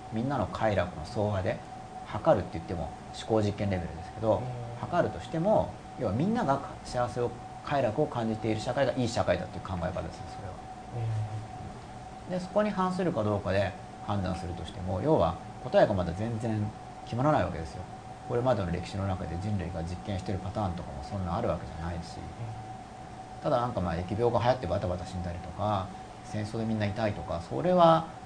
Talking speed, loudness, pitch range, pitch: 400 characters per minute, -31 LUFS, 95-120 Hz, 105 Hz